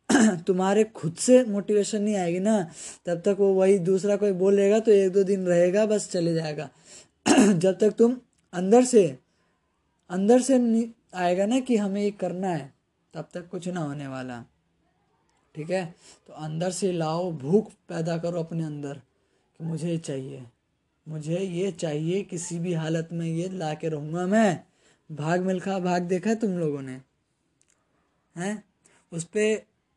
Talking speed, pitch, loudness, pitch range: 160 wpm, 180 Hz, -25 LUFS, 160-205 Hz